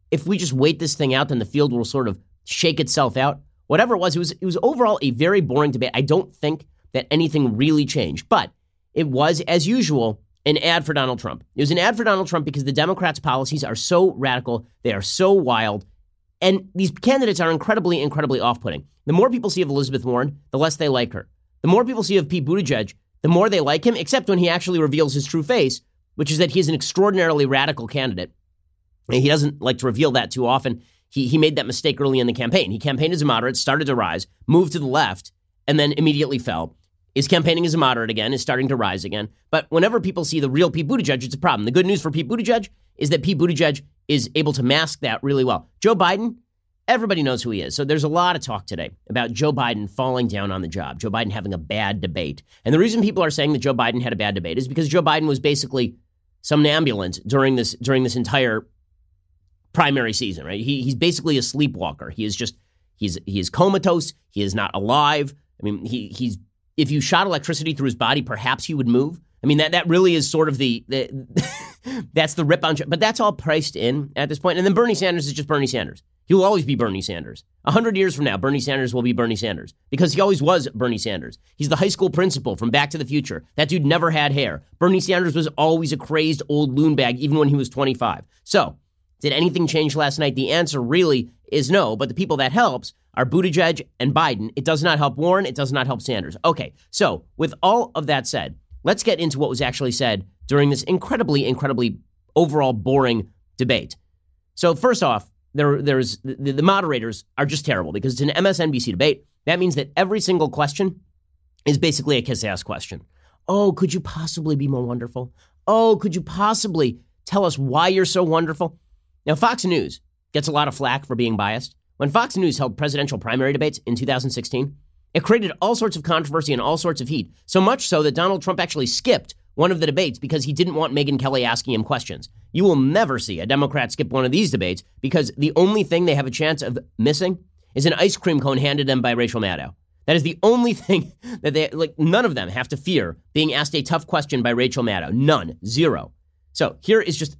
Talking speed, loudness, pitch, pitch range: 230 wpm, -20 LUFS, 145 Hz, 120-165 Hz